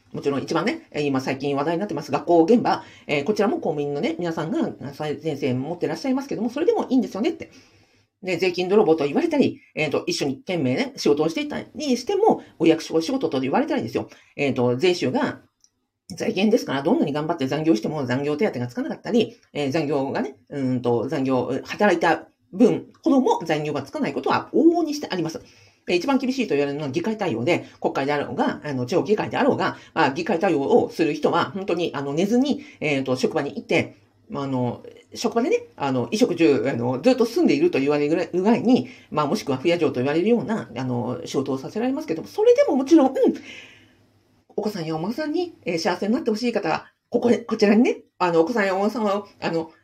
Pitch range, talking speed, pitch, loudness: 145-240 Hz, 430 characters per minute, 180 Hz, -22 LUFS